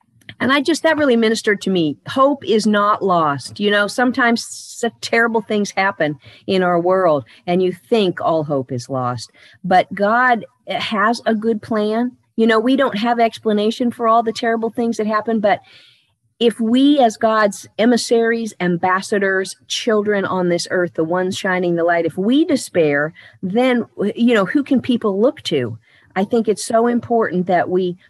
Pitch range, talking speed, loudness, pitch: 180-235 Hz, 175 wpm, -17 LUFS, 215 Hz